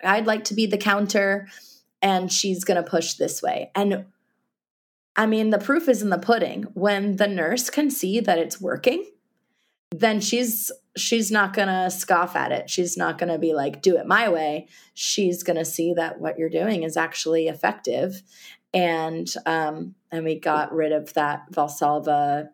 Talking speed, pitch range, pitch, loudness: 185 wpm, 165-210 Hz, 185 Hz, -23 LUFS